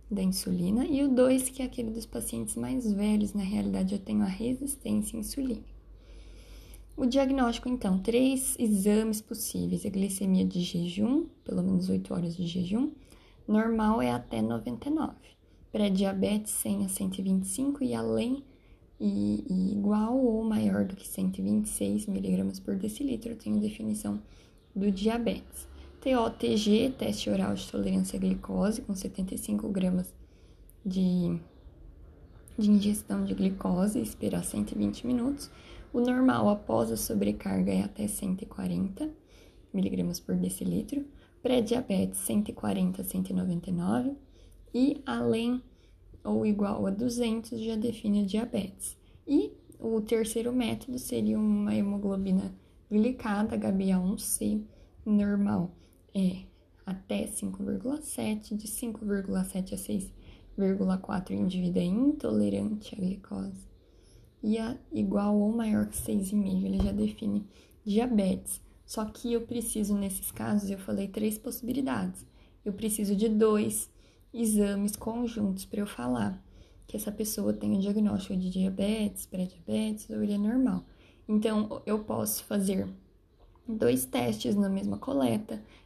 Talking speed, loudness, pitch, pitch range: 125 wpm, -30 LUFS, 205 Hz, 175-225 Hz